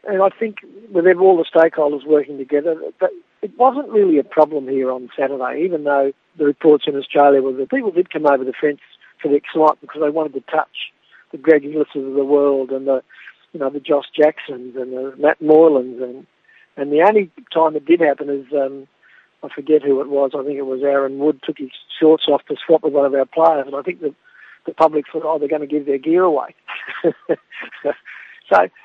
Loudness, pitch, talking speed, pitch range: -17 LUFS, 150 Hz, 220 wpm, 140-160 Hz